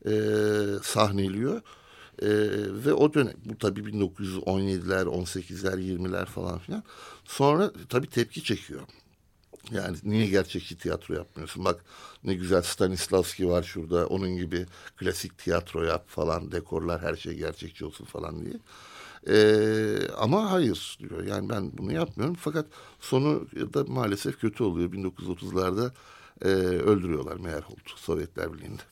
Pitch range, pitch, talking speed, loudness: 95-110 Hz, 100 Hz, 130 wpm, -28 LUFS